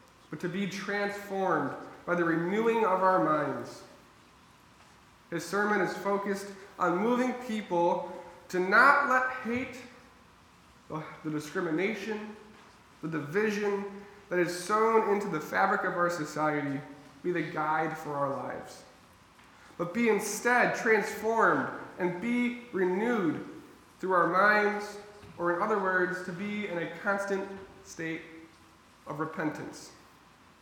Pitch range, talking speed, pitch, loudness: 170-210 Hz, 120 wpm, 190 Hz, -29 LUFS